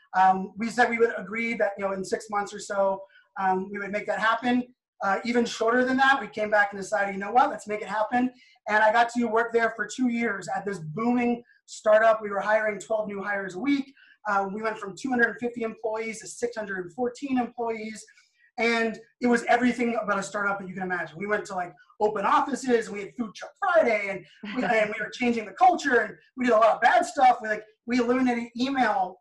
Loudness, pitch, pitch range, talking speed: -26 LUFS, 225 Hz, 205-245 Hz, 240 wpm